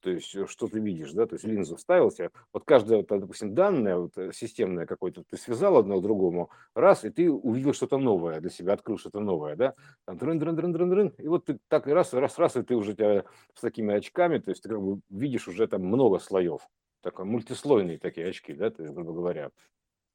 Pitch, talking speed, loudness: 135 Hz, 215 wpm, -27 LUFS